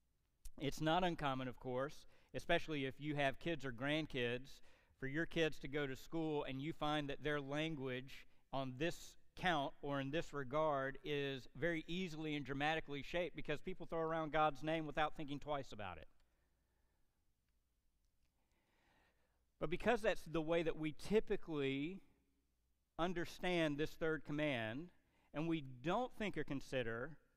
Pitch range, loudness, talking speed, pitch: 130-160 Hz, -42 LUFS, 145 wpm, 150 Hz